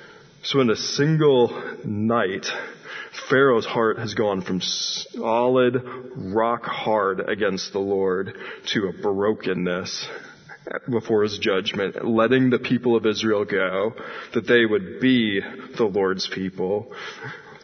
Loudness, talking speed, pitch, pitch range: -22 LUFS, 120 wpm, 115 Hz, 100-125 Hz